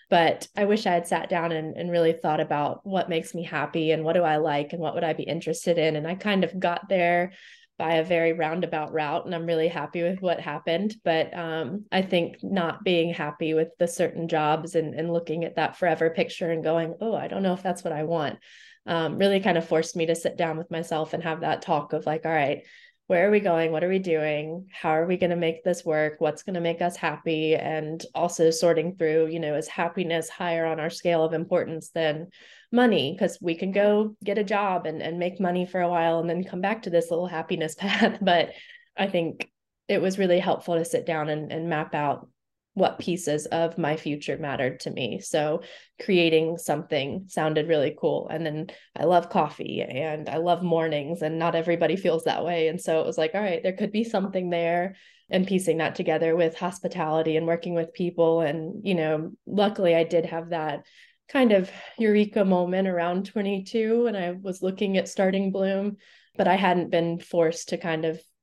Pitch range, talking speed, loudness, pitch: 160-185 Hz, 220 wpm, -26 LUFS, 170 Hz